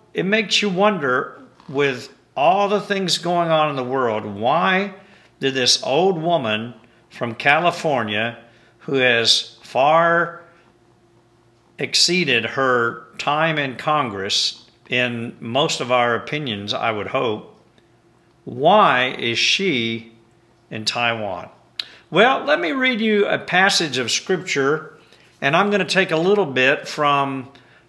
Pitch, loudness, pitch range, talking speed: 135 Hz, -19 LUFS, 115-175 Hz, 125 wpm